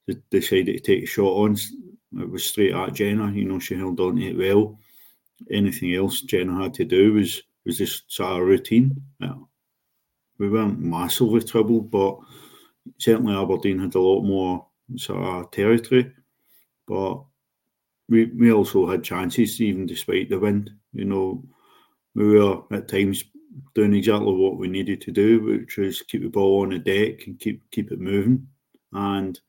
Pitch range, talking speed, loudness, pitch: 95-120 Hz, 170 wpm, -22 LUFS, 105 Hz